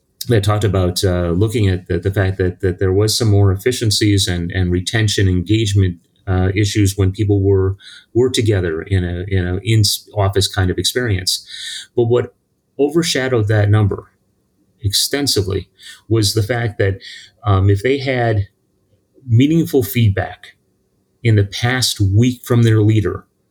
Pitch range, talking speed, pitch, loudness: 95-115 Hz, 150 wpm, 100 Hz, -16 LUFS